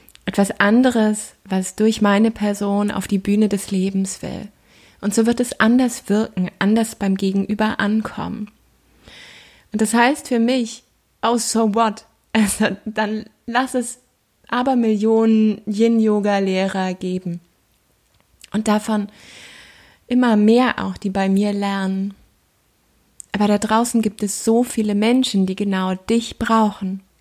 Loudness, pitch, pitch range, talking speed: -19 LUFS, 215 Hz, 200-225 Hz, 130 wpm